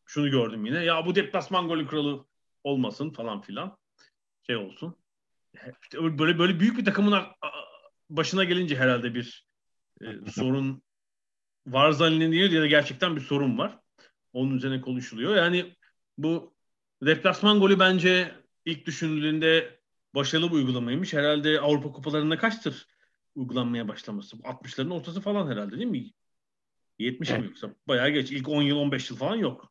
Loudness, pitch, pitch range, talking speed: -26 LUFS, 155 Hz, 135-175 Hz, 140 wpm